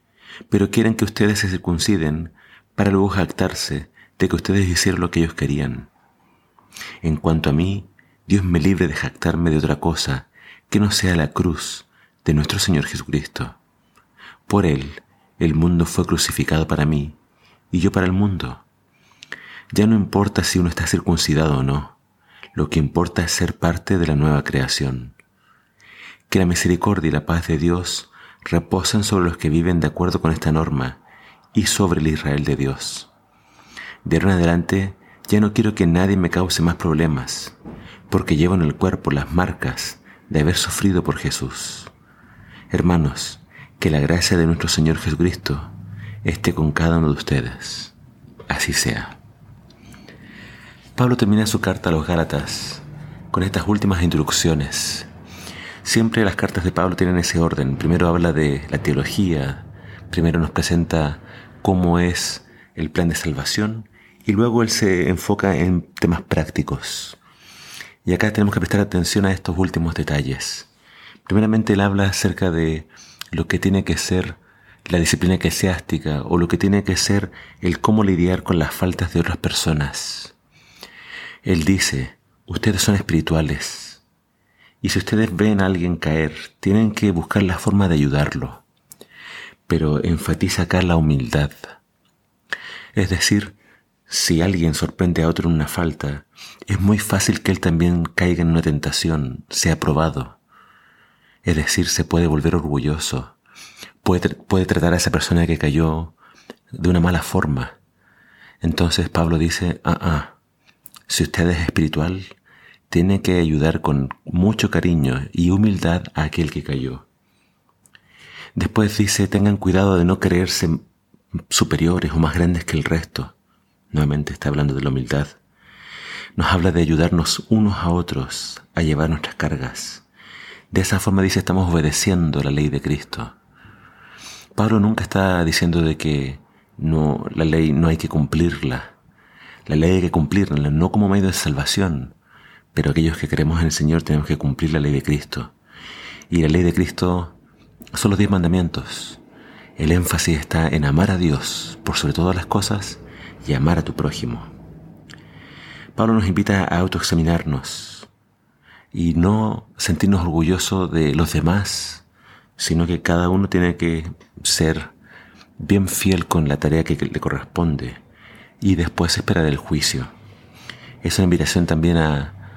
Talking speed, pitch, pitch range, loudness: 155 wpm, 85 Hz, 80-95 Hz, -19 LUFS